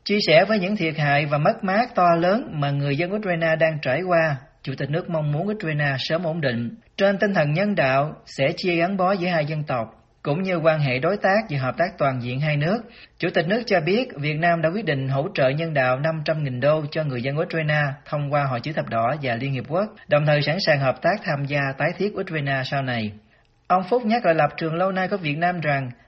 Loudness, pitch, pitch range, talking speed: -22 LUFS, 155 Hz, 140-180 Hz, 250 wpm